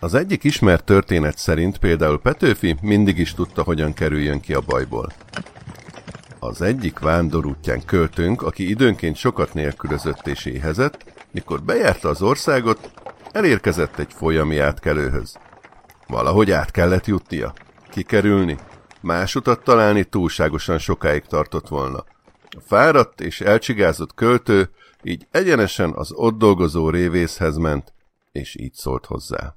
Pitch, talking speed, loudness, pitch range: 85 Hz, 125 wpm, -19 LUFS, 80-100 Hz